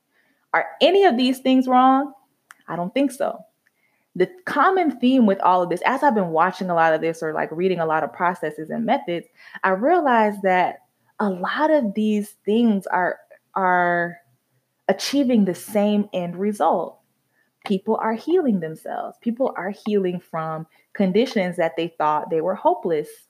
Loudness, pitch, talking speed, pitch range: -21 LUFS, 200 Hz, 165 wpm, 175-255 Hz